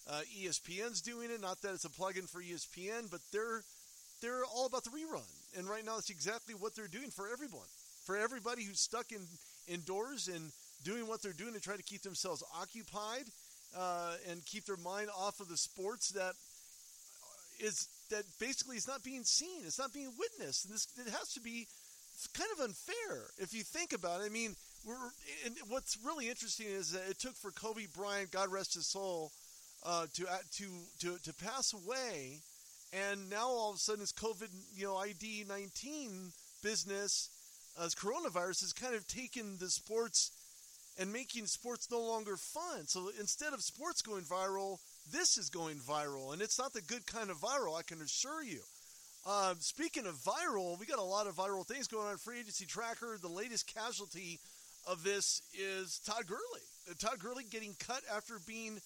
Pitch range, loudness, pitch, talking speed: 185-235 Hz, -41 LUFS, 210 Hz, 190 wpm